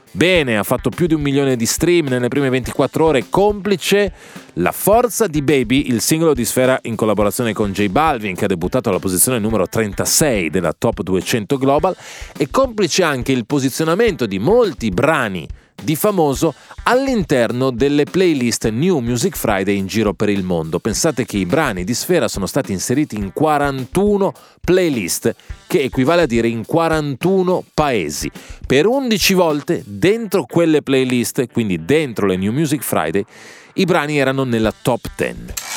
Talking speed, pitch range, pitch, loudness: 160 wpm, 115-170 Hz, 135 Hz, -17 LUFS